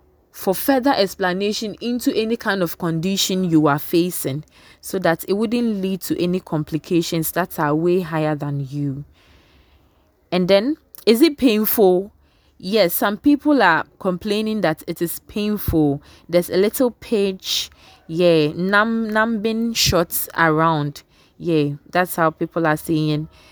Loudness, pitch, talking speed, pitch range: -19 LUFS, 175 Hz, 145 wpm, 155-210 Hz